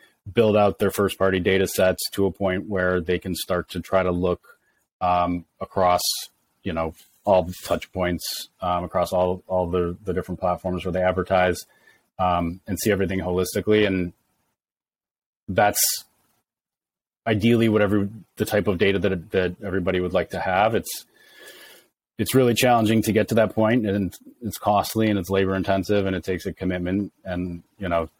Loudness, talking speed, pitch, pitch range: -23 LUFS, 170 wpm, 95 Hz, 90-100 Hz